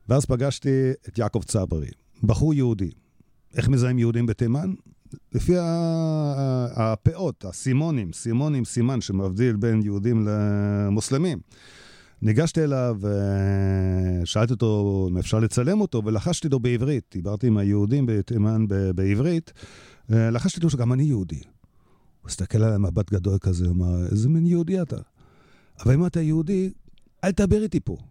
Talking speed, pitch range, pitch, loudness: 130 wpm, 100-140 Hz, 115 Hz, -23 LUFS